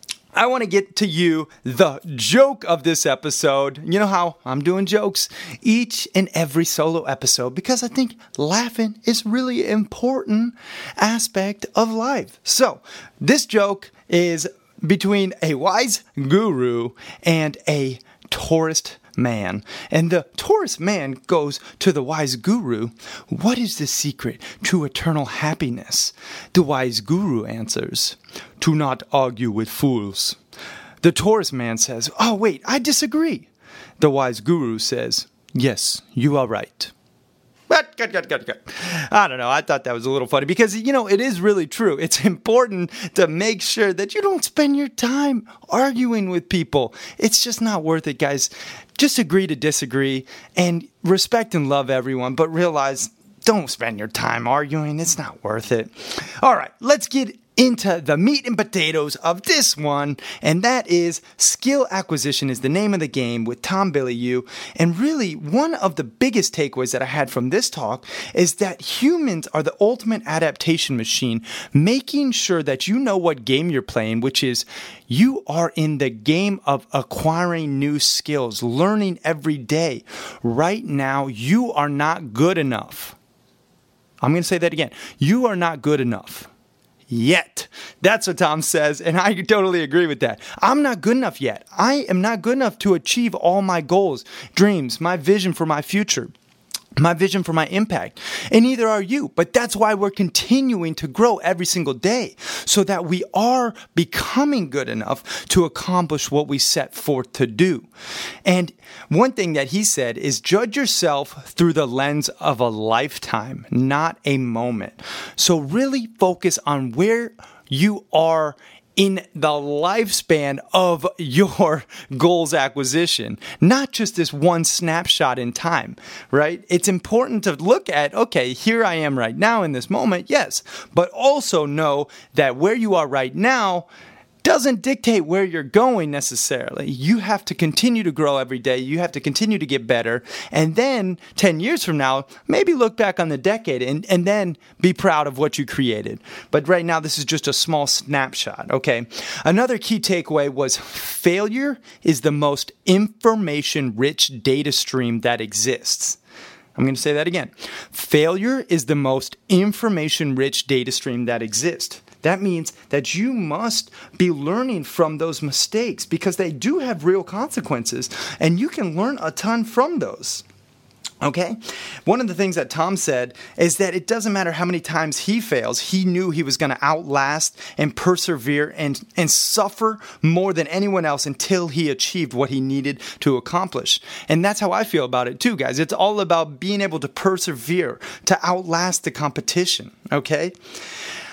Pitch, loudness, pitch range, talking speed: 170 Hz, -20 LUFS, 140-205 Hz, 165 wpm